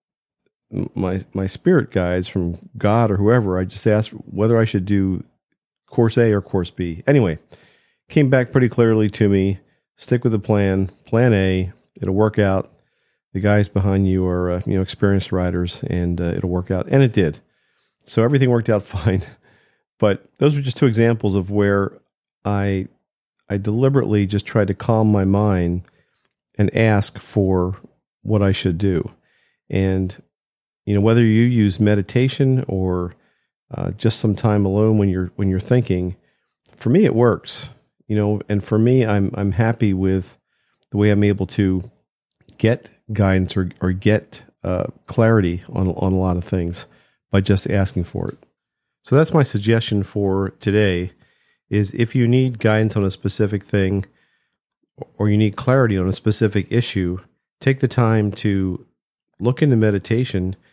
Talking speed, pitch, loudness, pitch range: 165 wpm, 100 Hz, -19 LUFS, 95-115 Hz